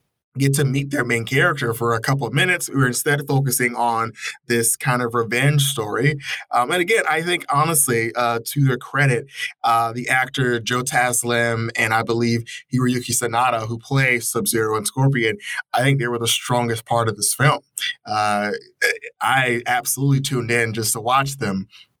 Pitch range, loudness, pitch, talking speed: 115-140 Hz, -19 LUFS, 120 Hz, 185 wpm